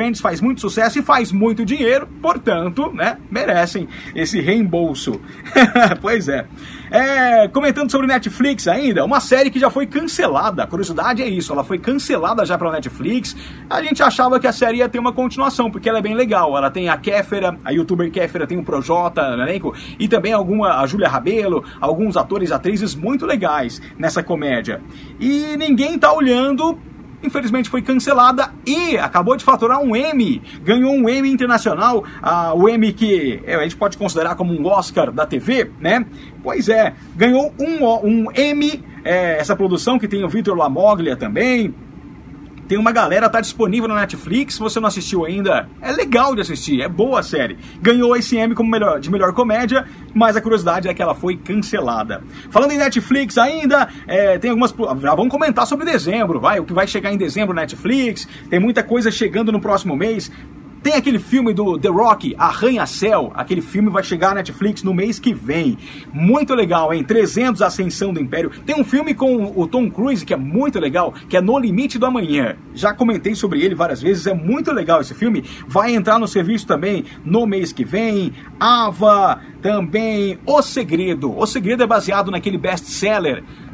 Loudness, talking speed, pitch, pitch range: -17 LUFS, 185 wpm, 220 Hz, 190-255 Hz